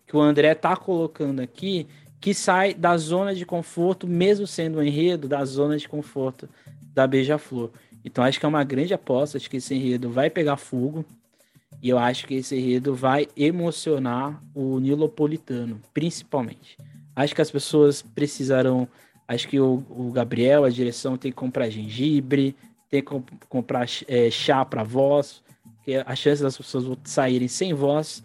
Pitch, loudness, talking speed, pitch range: 140 Hz, -23 LUFS, 170 wpm, 130-150 Hz